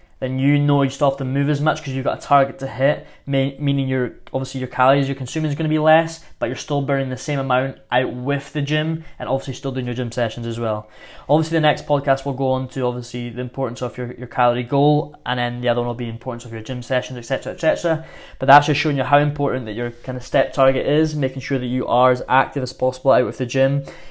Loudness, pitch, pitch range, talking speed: -20 LUFS, 135 Hz, 125-145 Hz, 270 wpm